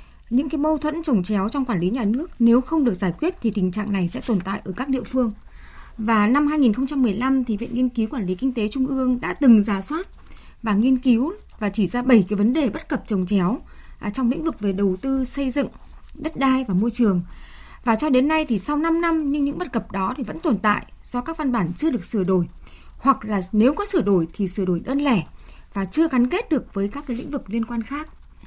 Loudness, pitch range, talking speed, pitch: -22 LUFS, 210-280 Hz, 255 wpm, 245 Hz